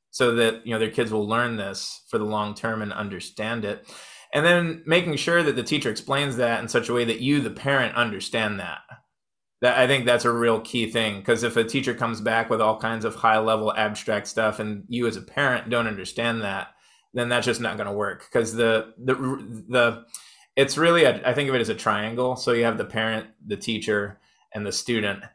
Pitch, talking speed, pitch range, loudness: 115 Hz, 225 wpm, 110-125 Hz, -24 LUFS